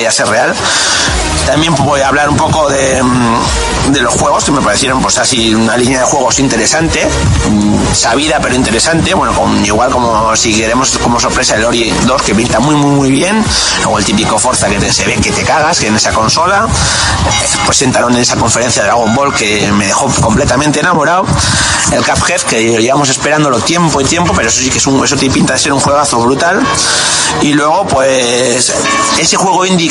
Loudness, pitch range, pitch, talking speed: -9 LUFS, 115-145 Hz, 130 Hz, 200 wpm